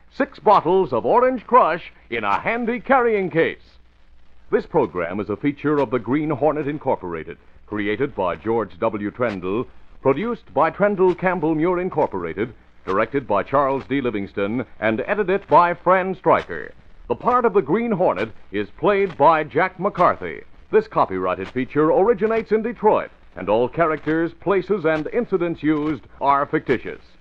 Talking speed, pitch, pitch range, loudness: 150 wpm, 155 Hz, 125-200 Hz, -20 LUFS